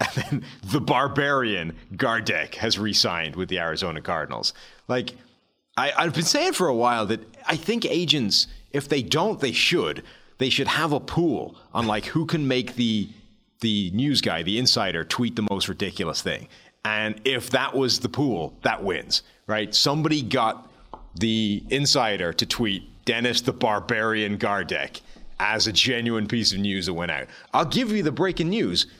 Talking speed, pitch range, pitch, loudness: 170 wpm, 105-140 Hz, 120 Hz, -23 LUFS